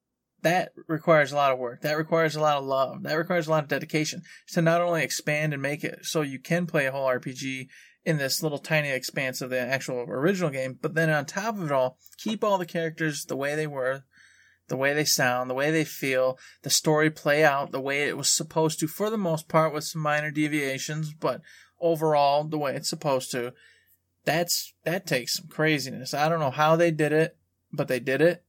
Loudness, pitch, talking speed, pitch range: -26 LUFS, 150 Hz, 225 wpm, 135-165 Hz